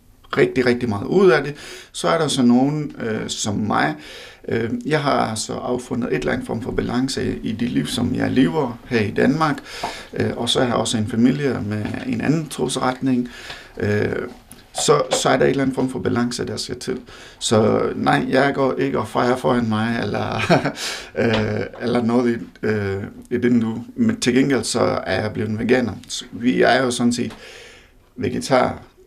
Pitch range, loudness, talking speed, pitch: 115-130 Hz, -20 LUFS, 185 wpm, 125 Hz